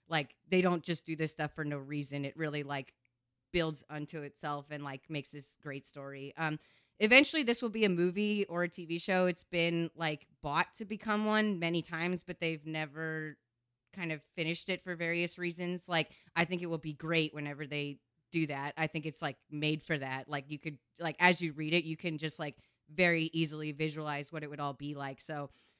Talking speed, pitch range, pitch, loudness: 215 wpm, 145-175 Hz, 160 Hz, -34 LUFS